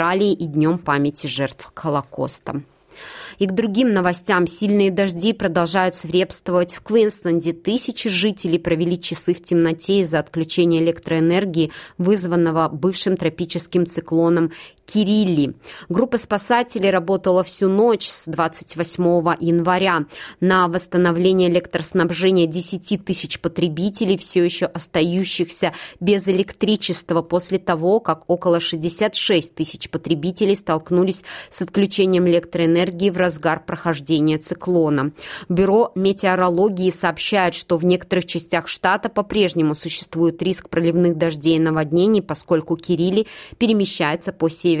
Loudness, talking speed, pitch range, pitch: -19 LUFS, 110 wpm, 170-195 Hz, 175 Hz